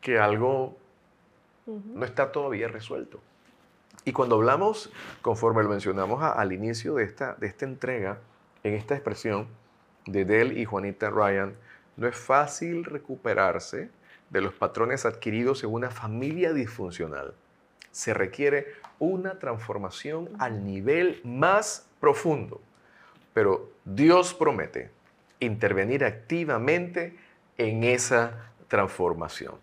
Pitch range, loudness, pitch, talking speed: 110-175 Hz, -27 LUFS, 130 Hz, 110 wpm